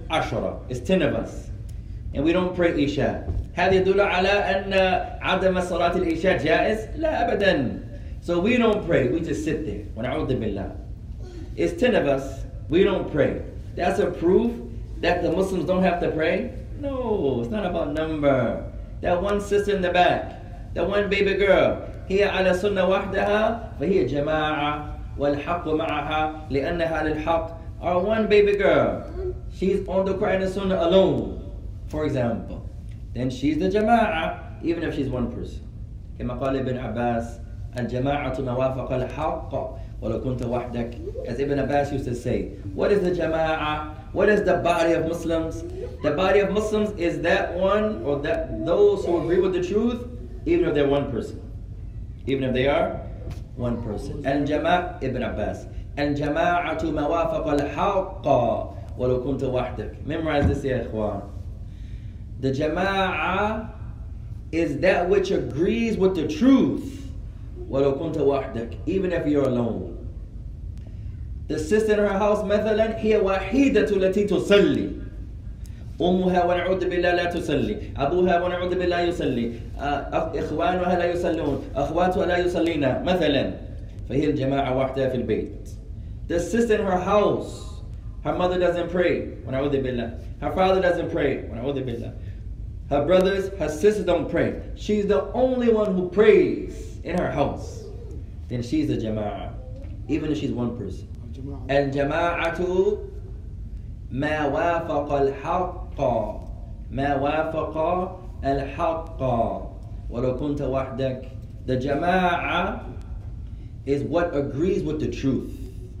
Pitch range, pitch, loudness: 110-180 Hz, 140 Hz, -23 LUFS